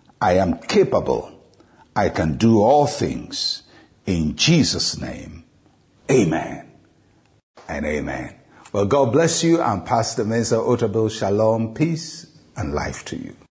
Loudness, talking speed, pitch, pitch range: -20 LUFS, 125 wpm, 115 Hz, 105-145 Hz